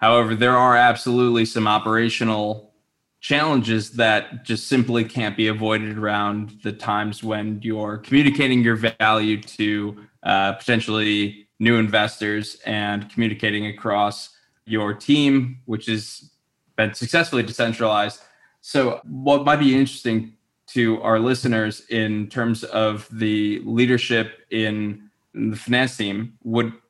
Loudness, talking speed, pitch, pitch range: -21 LUFS, 120 wpm, 110 Hz, 105-120 Hz